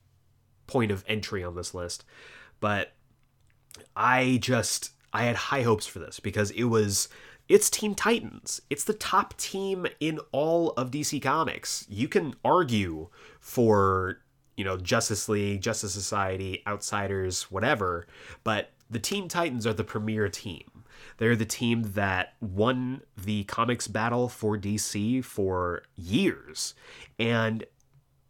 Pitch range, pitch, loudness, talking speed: 105-125 Hz, 110 Hz, -28 LUFS, 135 wpm